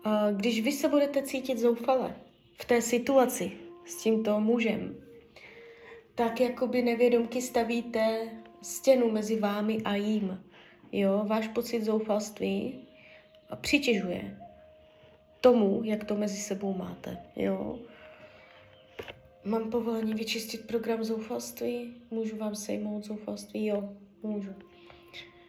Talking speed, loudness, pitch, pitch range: 110 wpm, -30 LUFS, 220 Hz, 200-240 Hz